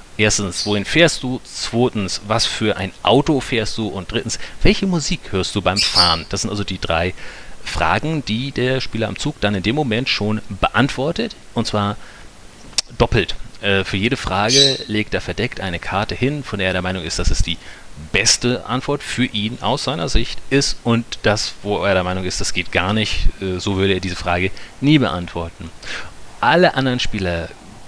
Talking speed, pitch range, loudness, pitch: 190 wpm, 95-125 Hz, -18 LUFS, 105 Hz